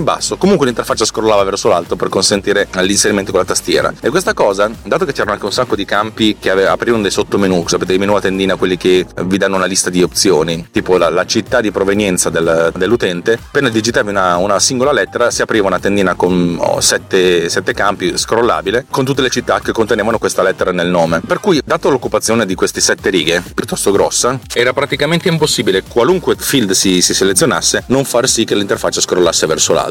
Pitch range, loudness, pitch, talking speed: 90-110 Hz, -13 LUFS, 95 Hz, 205 wpm